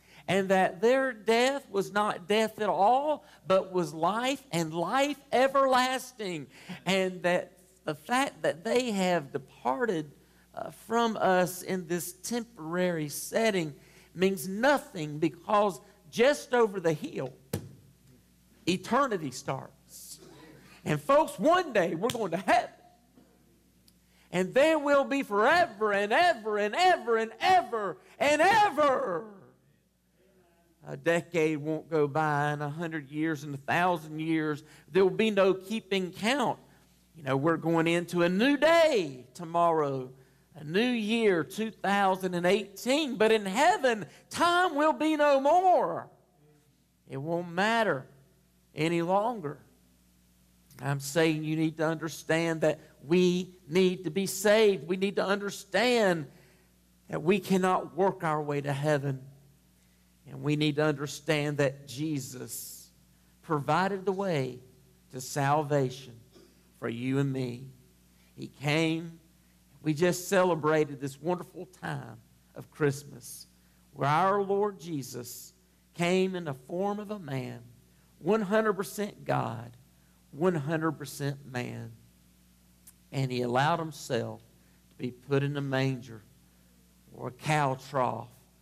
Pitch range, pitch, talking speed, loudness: 140-200 Hz, 170 Hz, 125 wpm, -28 LUFS